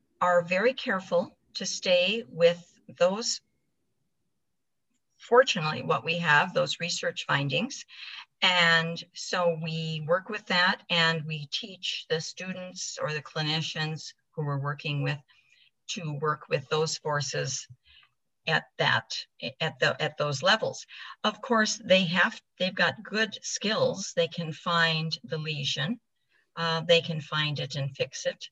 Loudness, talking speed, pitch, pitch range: -27 LUFS, 135 wpm, 170 Hz, 155-185 Hz